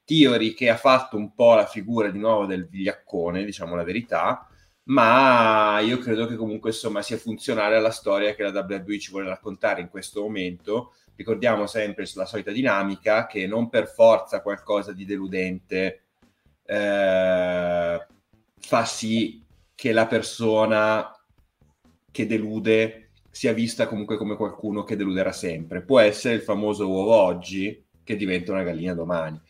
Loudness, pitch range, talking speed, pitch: -23 LUFS, 95-110 Hz, 150 wpm, 105 Hz